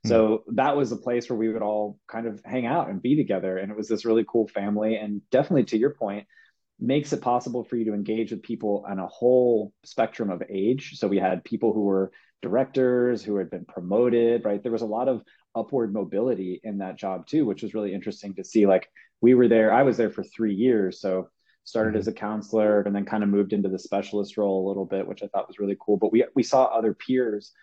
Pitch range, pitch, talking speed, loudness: 100-115 Hz, 110 Hz, 240 wpm, -25 LUFS